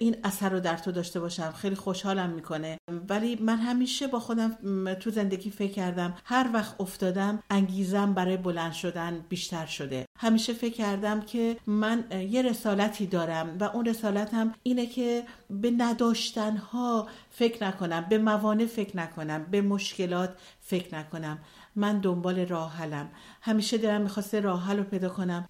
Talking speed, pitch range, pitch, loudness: 150 wpm, 180-225 Hz, 200 Hz, -29 LUFS